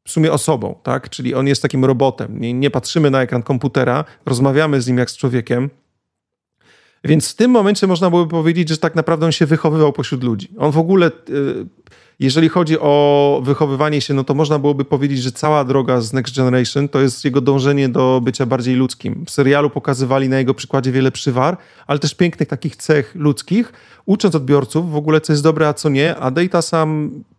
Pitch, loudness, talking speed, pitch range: 145 Hz, -16 LUFS, 195 wpm, 135-160 Hz